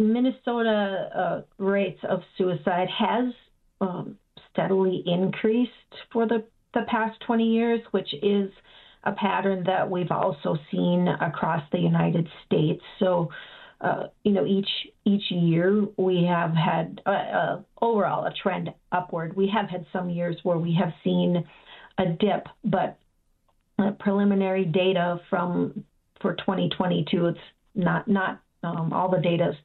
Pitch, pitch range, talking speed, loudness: 190 Hz, 175-205 Hz, 140 wpm, -25 LUFS